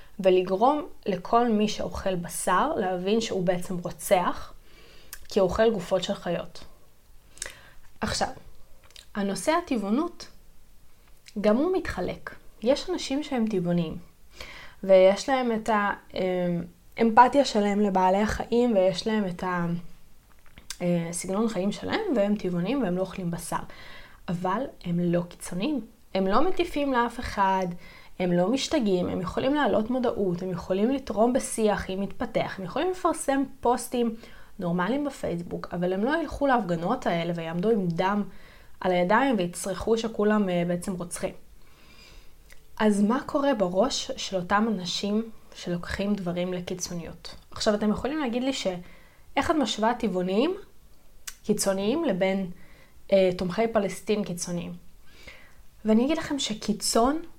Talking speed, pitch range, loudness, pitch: 120 wpm, 185-245 Hz, -26 LUFS, 205 Hz